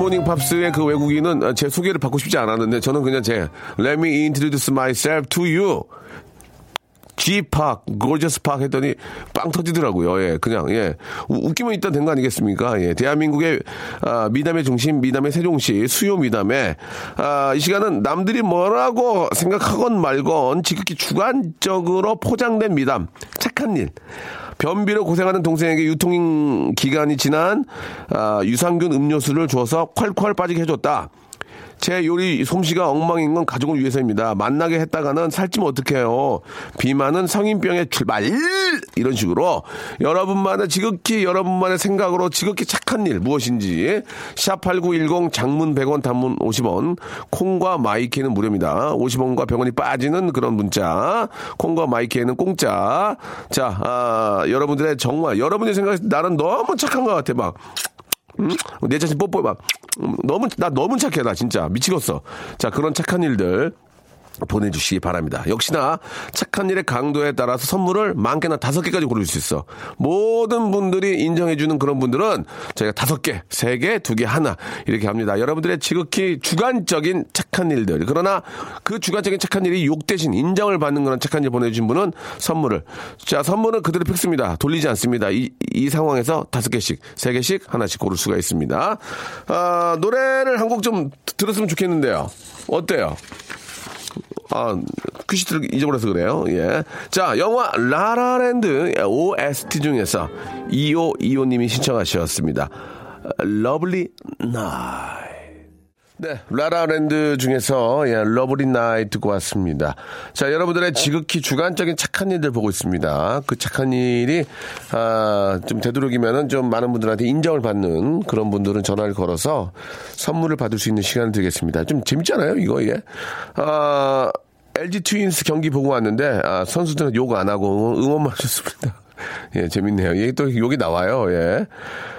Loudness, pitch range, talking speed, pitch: -19 LUFS, 125-180 Hz, 325 characters per minute, 150 Hz